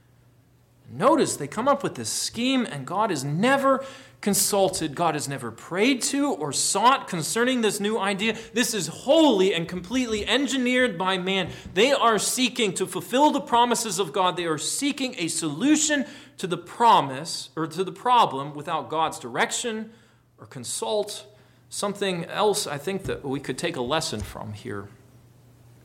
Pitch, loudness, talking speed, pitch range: 190 Hz, -24 LUFS, 160 wpm, 140-230 Hz